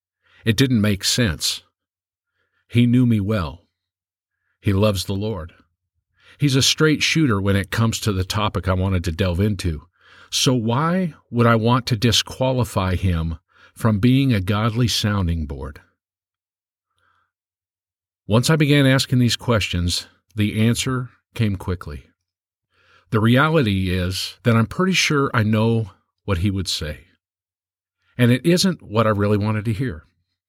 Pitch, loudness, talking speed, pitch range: 105 Hz, -19 LUFS, 145 wpm, 90-120 Hz